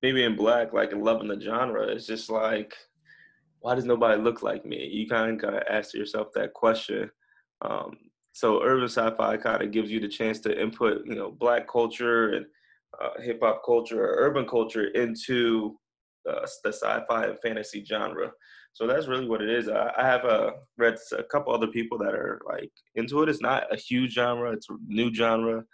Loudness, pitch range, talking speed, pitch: -27 LUFS, 110-125 Hz, 210 wpm, 115 Hz